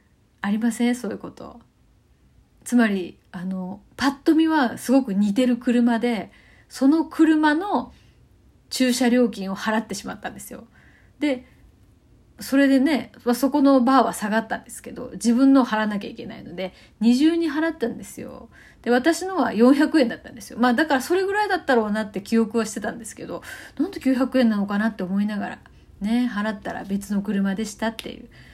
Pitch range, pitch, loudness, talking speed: 215-270 Hz, 240 Hz, -22 LUFS, 345 characters per minute